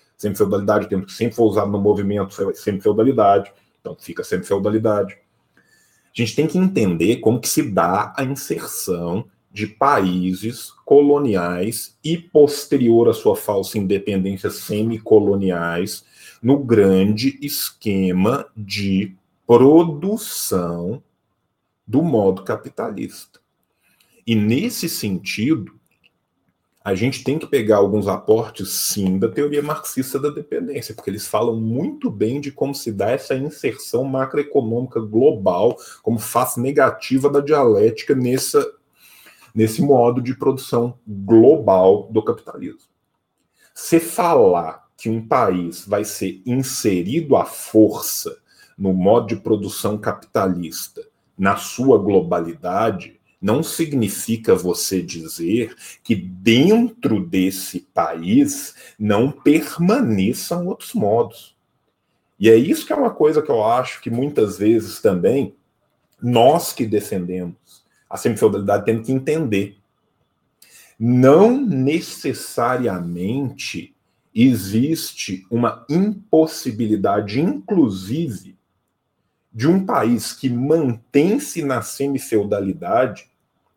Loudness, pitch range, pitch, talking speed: -18 LUFS, 100-145 Hz, 120 Hz, 110 wpm